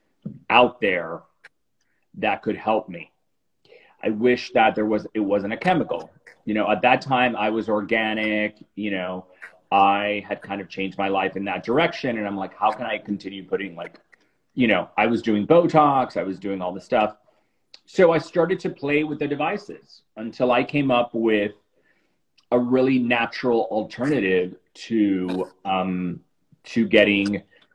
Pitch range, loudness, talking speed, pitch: 100-125 Hz, -22 LUFS, 165 wpm, 110 Hz